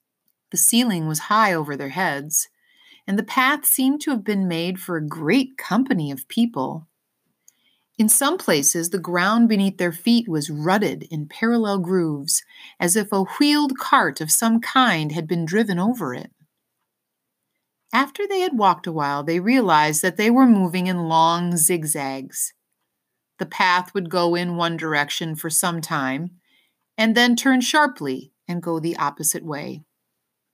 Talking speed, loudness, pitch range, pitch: 160 wpm, -20 LUFS, 160-235 Hz, 180 Hz